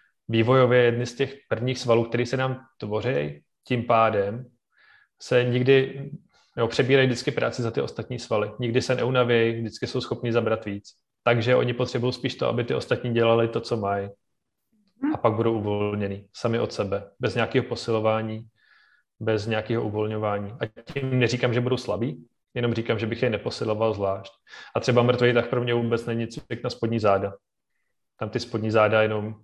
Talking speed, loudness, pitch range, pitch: 175 wpm, -25 LUFS, 110-125 Hz, 115 Hz